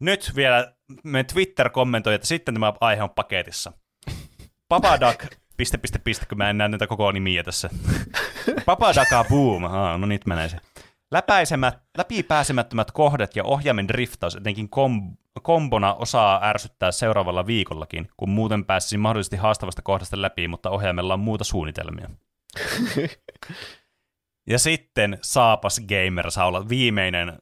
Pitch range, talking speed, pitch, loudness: 95-120 Hz, 135 wpm, 105 Hz, -22 LUFS